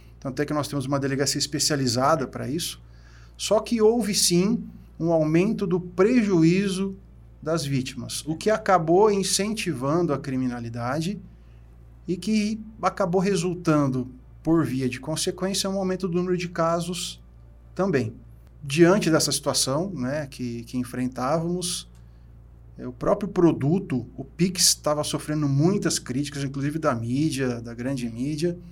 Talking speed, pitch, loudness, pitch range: 130 wpm, 150 Hz, -24 LUFS, 125-180 Hz